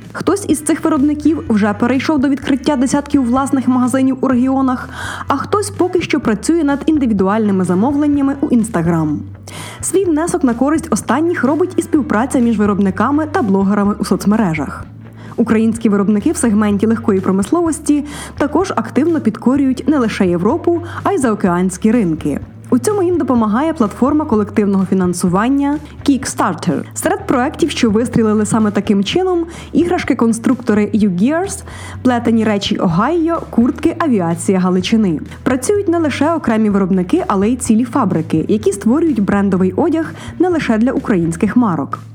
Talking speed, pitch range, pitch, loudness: 135 wpm, 205-295 Hz, 240 Hz, -15 LUFS